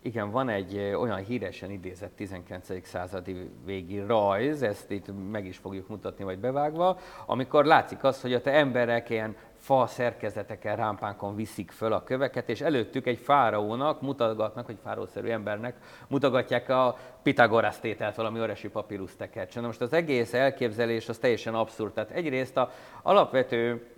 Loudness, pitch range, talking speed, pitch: -28 LUFS, 105-125 Hz, 150 wpm, 115 Hz